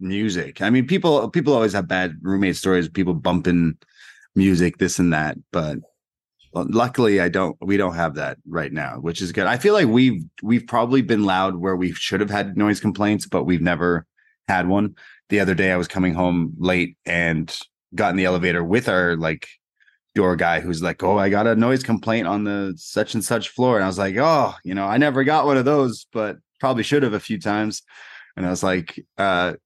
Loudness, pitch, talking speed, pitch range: -20 LUFS, 95 Hz, 215 wpm, 90-110 Hz